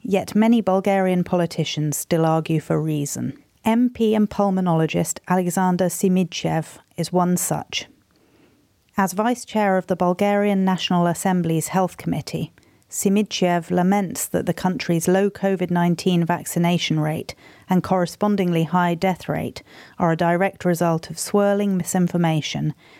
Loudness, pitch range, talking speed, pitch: -21 LUFS, 170-195 Hz, 125 wpm, 180 Hz